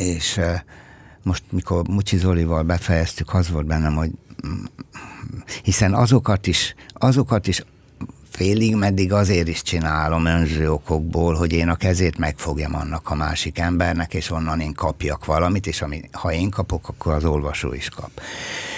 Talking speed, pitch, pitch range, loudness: 145 wpm, 85 Hz, 80-95 Hz, -21 LUFS